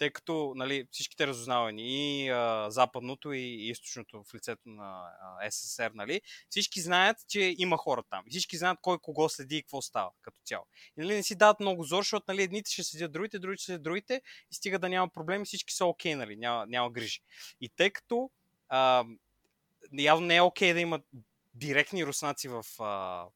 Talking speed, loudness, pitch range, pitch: 200 wpm, -31 LUFS, 125-185 Hz, 155 Hz